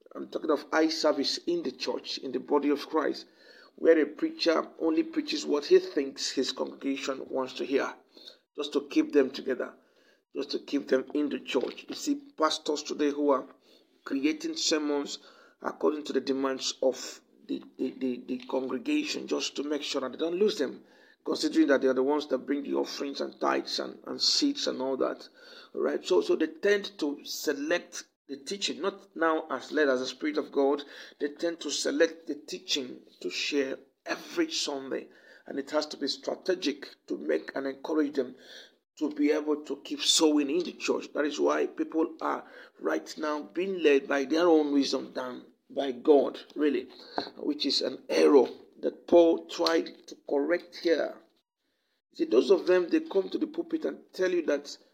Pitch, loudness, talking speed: 160 Hz, -29 LUFS, 185 wpm